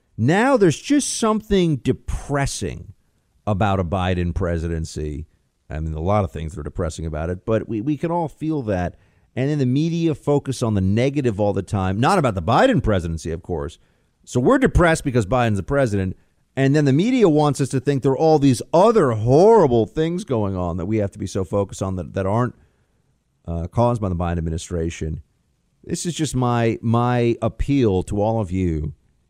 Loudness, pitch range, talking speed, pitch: -20 LUFS, 90-135 Hz, 195 wpm, 105 Hz